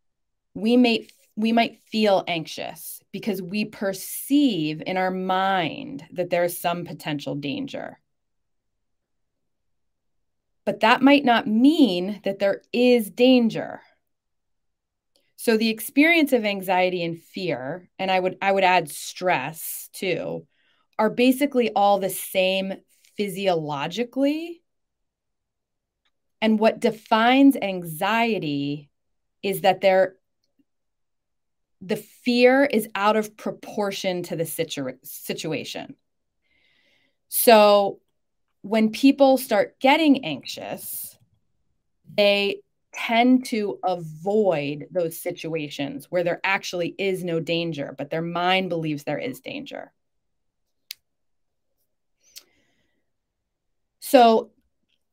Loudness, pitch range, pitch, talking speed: -22 LUFS, 175-235 Hz, 195 Hz, 100 wpm